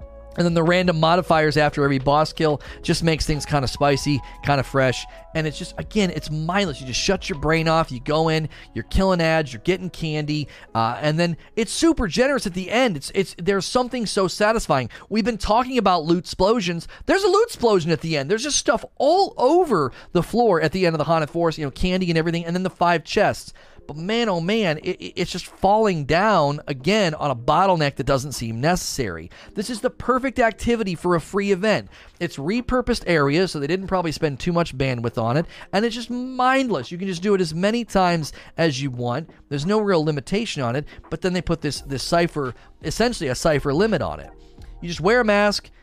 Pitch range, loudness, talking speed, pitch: 150-205 Hz, -21 LUFS, 220 wpm, 170 Hz